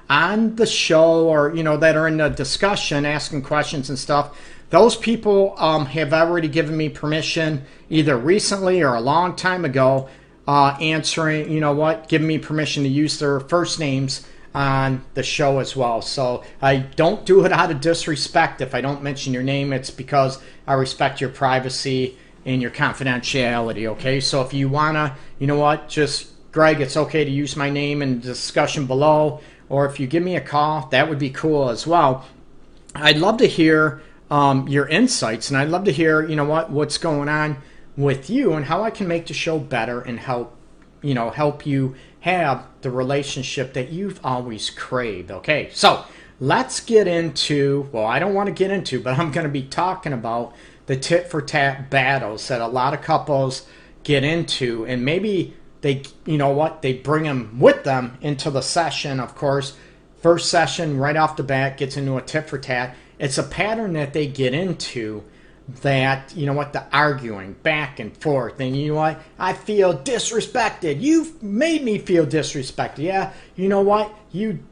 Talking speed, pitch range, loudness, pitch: 190 wpm, 135-160 Hz, -20 LUFS, 145 Hz